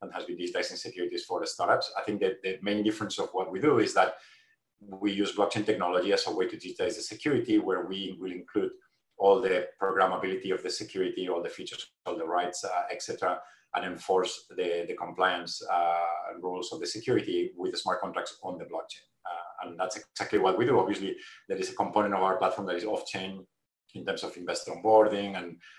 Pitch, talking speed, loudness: 105 Hz, 210 wpm, -30 LUFS